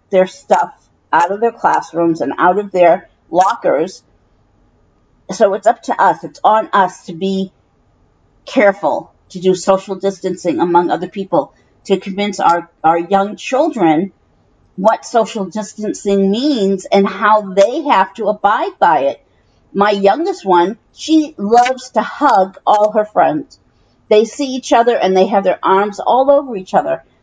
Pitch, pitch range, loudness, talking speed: 195 Hz, 180-215 Hz, -14 LUFS, 155 wpm